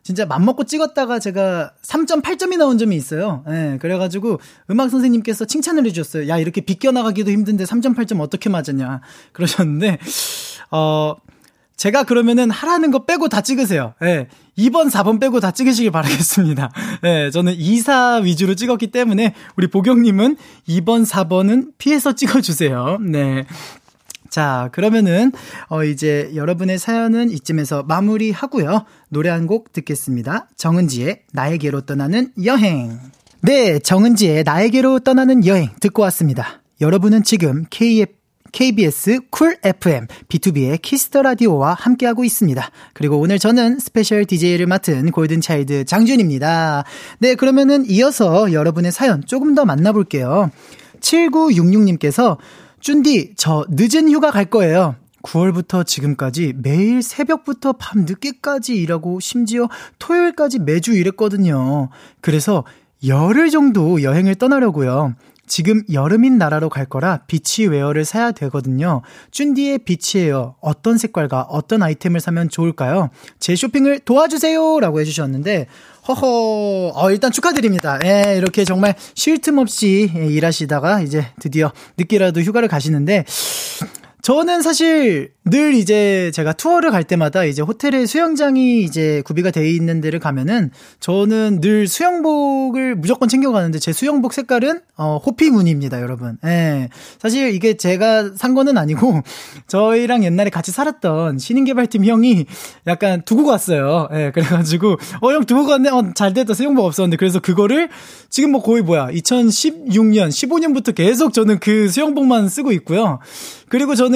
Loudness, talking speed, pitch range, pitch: -16 LUFS, 325 characters per minute, 160-250 Hz, 200 Hz